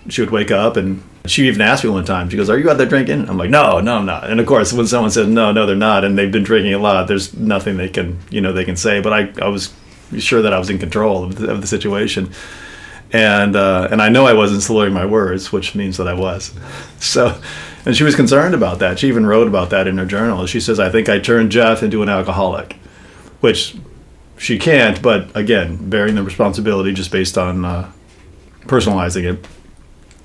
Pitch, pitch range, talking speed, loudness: 100 Hz, 95-110 Hz, 235 wpm, -14 LUFS